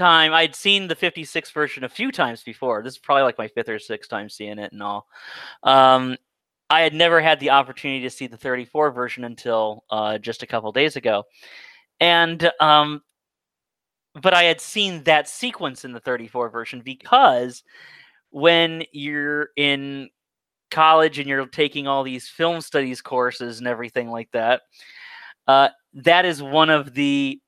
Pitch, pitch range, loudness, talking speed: 140 Hz, 125-165 Hz, -19 LUFS, 170 wpm